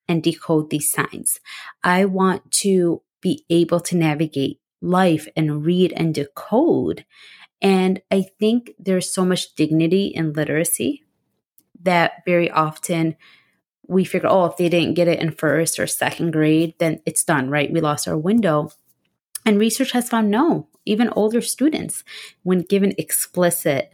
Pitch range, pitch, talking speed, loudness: 160-195 Hz, 175 Hz, 150 wpm, -19 LUFS